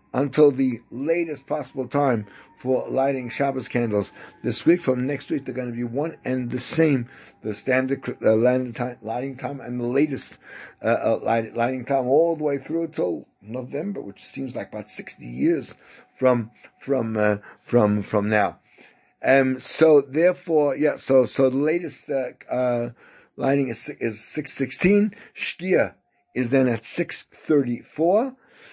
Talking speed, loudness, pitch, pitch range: 155 wpm, -23 LUFS, 130 Hz, 120-150 Hz